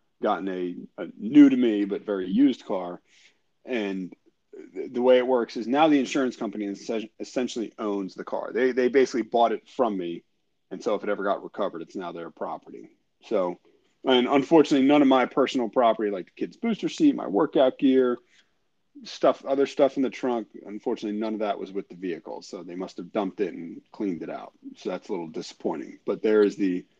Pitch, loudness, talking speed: 130 Hz, -25 LUFS, 200 wpm